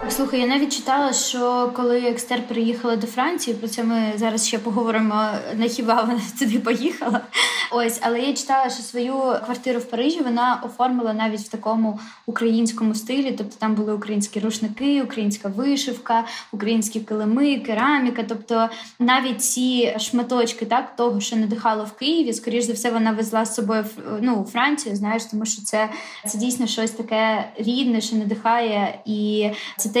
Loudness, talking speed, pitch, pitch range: -22 LUFS, 160 wpm, 230 Hz, 220-245 Hz